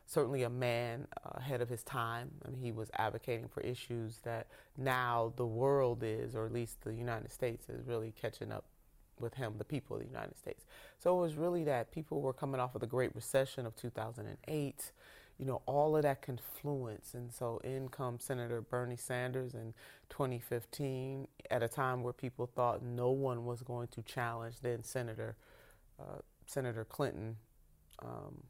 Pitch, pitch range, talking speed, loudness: 125 Hz, 115-135 Hz, 180 wpm, -39 LUFS